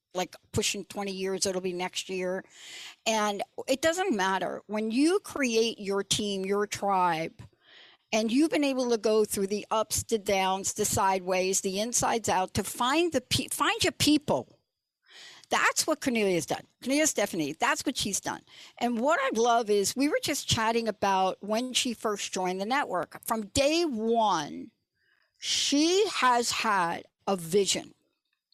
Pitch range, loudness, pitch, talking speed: 195-270 Hz, -28 LUFS, 220 Hz, 160 wpm